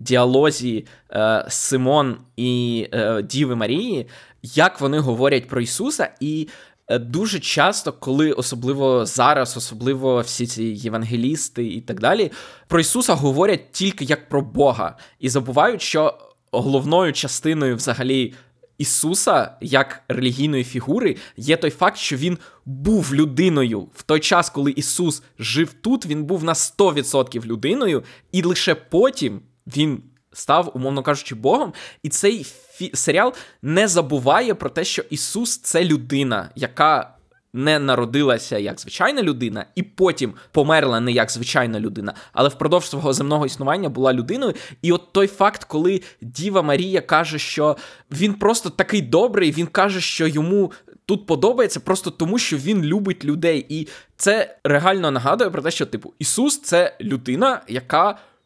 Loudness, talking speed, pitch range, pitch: -20 LUFS, 145 wpm, 130-175 Hz, 150 Hz